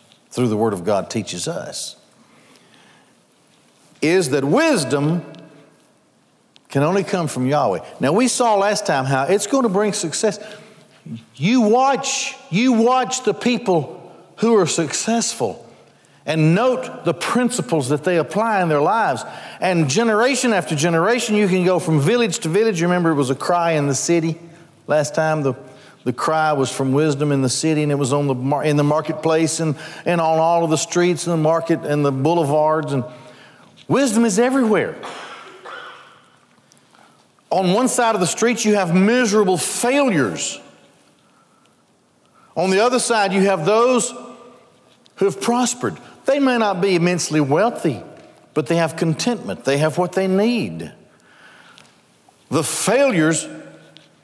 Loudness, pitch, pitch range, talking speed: -18 LUFS, 175 Hz, 155-225 Hz, 155 wpm